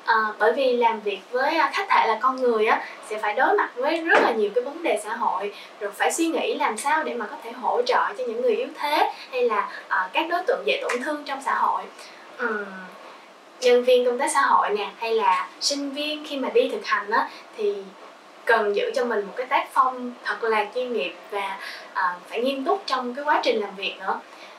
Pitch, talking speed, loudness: 300 Hz, 235 wpm, -23 LUFS